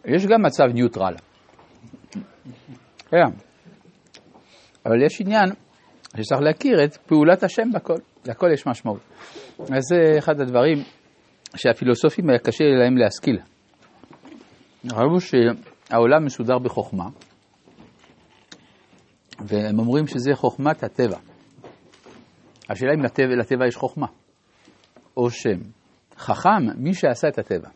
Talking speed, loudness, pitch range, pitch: 105 wpm, -20 LUFS, 120-155 Hz, 135 Hz